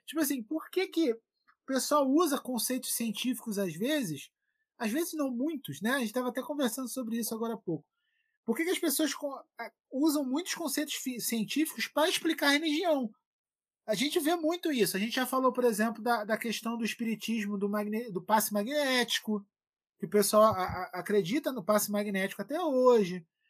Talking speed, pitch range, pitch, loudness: 185 wpm, 220-300 Hz, 250 Hz, -31 LUFS